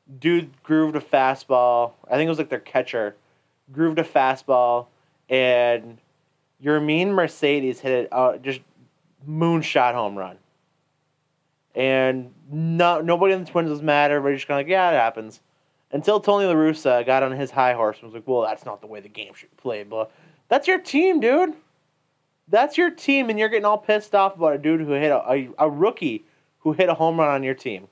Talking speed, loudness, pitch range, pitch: 200 wpm, -21 LUFS, 130-170 Hz, 150 Hz